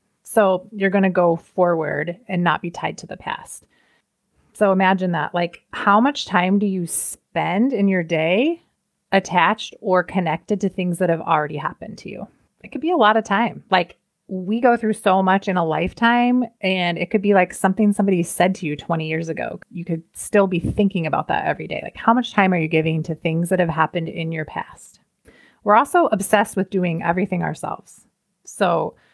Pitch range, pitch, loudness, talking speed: 175-210 Hz, 190 Hz, -20 LUFS, 200 wpm